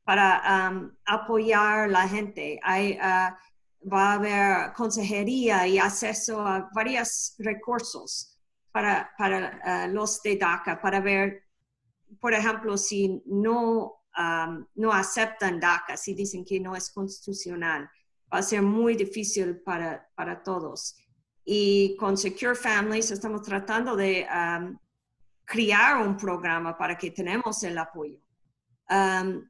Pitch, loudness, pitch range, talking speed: 195 Hz, -26 LUFS, 185-215 Hz, 130 wpm